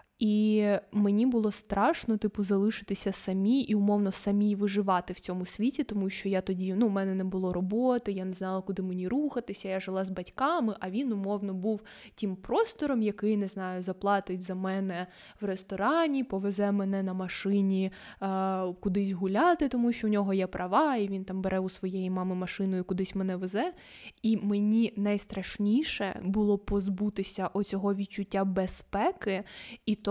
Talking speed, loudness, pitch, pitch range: 165 wpm, -30 LUFS, 200 Hz, 190-215 Hz